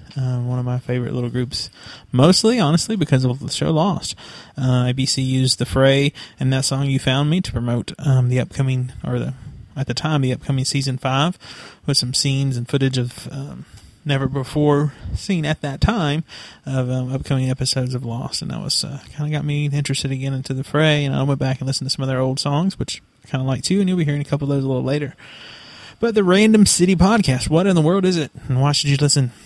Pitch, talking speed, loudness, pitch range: 135 Hz, 235 wpm, -19 LUFS, 130-150 Hz